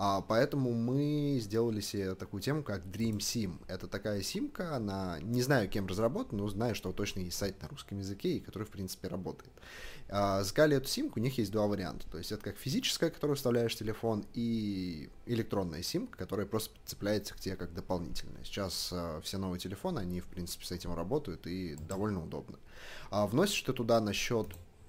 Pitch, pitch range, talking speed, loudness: 100 Hz, 95-115 Hz, 180 wpm, -35 LUFS